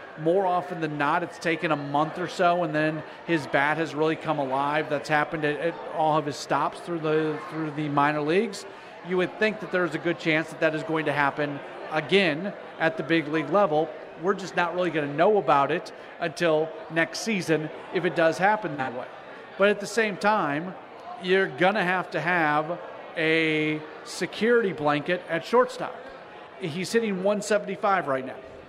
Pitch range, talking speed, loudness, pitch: 155-180 Hz, 190 wpm, -25 LUFS, 165 Hz